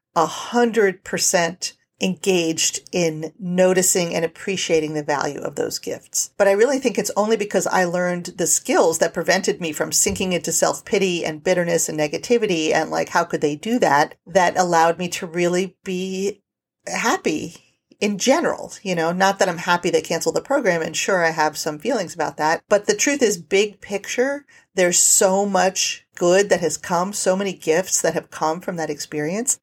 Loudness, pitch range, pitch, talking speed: -20 LUFS, 165-200 Hz, 185 Hz, 185 wpm